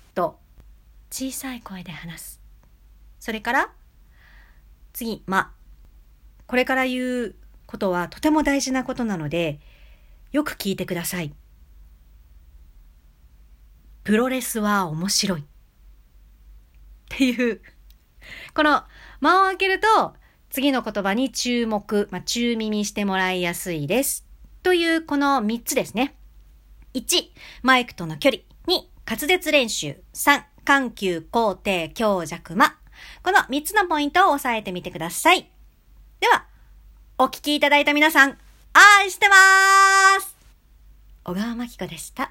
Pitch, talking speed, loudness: 220 Hz, 225 characters per minute, -20 LUFS